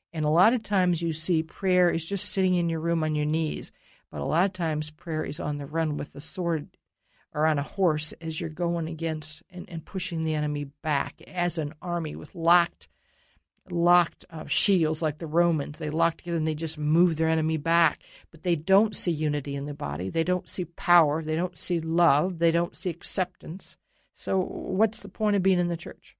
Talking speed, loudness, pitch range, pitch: 215 wpm, -26 LUFS, 155-180 Hz, 165 Hz